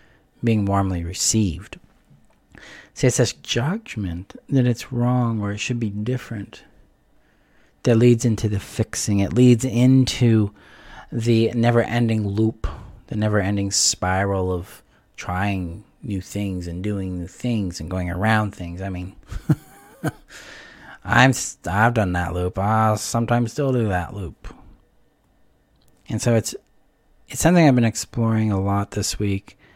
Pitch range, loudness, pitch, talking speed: 95-120 Hz, -21 LUFS, 105 Hz, 135 wpm